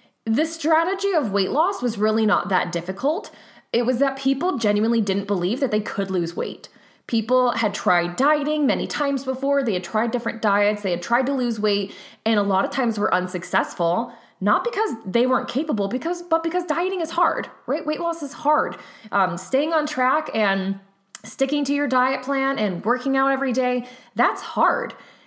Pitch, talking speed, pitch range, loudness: 245 Hz, 190 wpm, 205-280 Hz, -22 LUFS